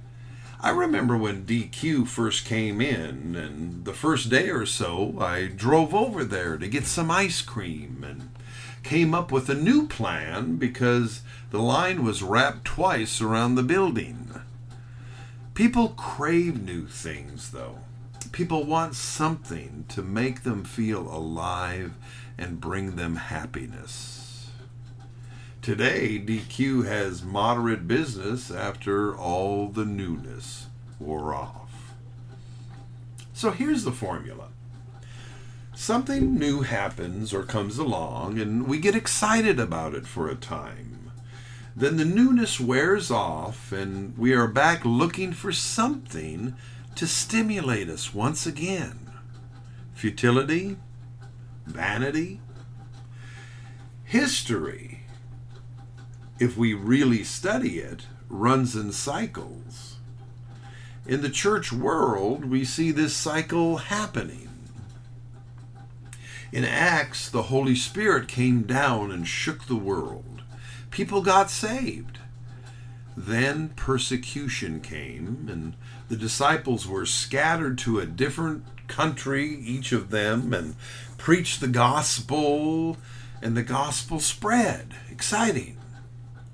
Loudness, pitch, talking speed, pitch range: -25 LUFS, 120 Hz, 110 wpm, 120-130 Hz